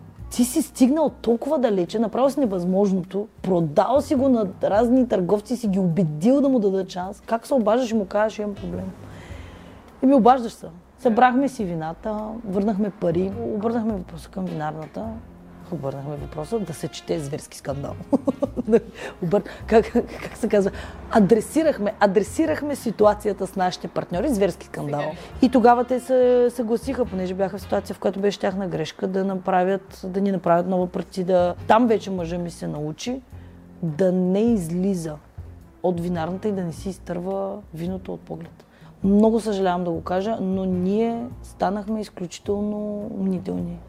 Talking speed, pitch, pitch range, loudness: 155 wpm, 200 Hz, 180-230 Hz, -23 LUFS